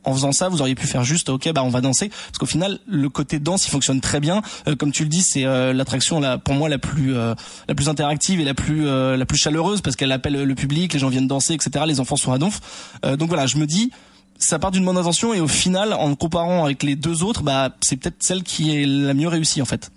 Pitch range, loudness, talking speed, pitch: 135-170 Hz, -20 LUFS, 285 wpm, 150 Hz